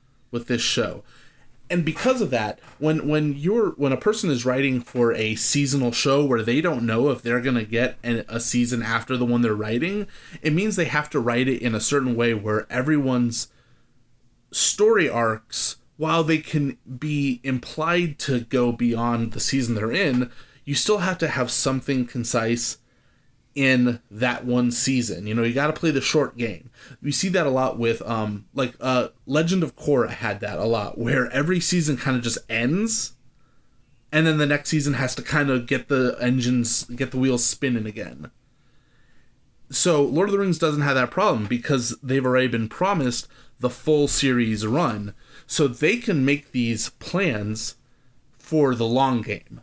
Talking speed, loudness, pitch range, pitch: 185 wpm, -22 LUFS, 120-145 Hz, 130 Hz